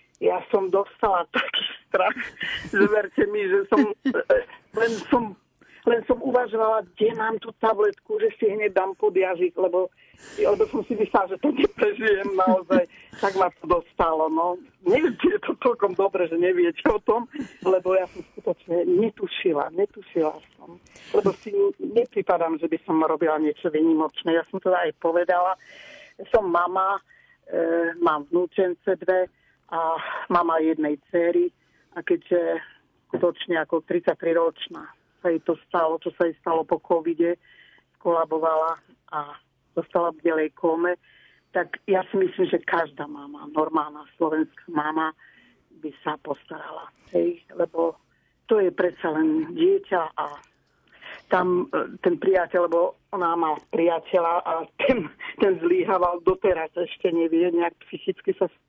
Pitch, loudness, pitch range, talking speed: 180 Hz, -24 LUFS, 165-225 Hz, 140 wpm